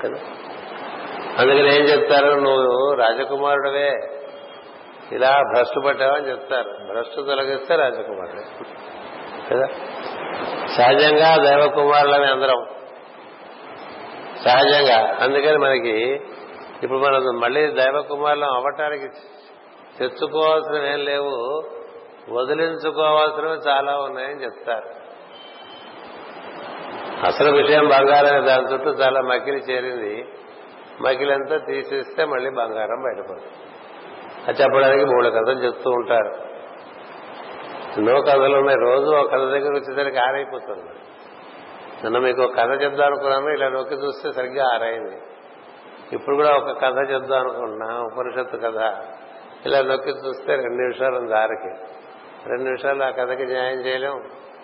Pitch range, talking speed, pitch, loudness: 130-150 Hz, 100 wpm, 140 Hz, -19 LUFS